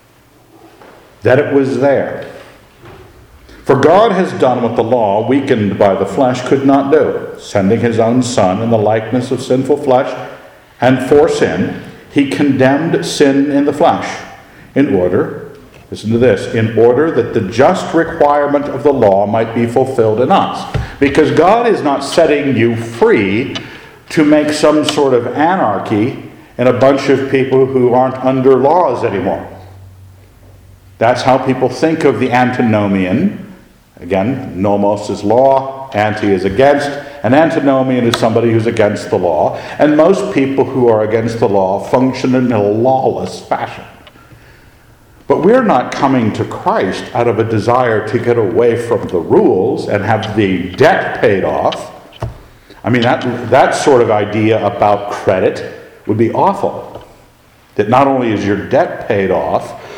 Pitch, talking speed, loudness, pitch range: 125 Hz, 155 wpm, -12 LUFS, 110-140 Hz